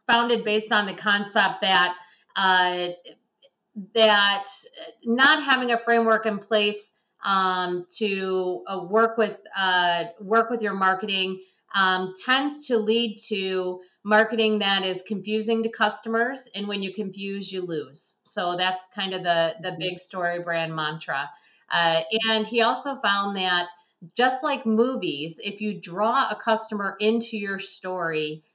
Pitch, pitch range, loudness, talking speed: 200 Hz, 185-225 Hz, -23 LUFS, 145 wpm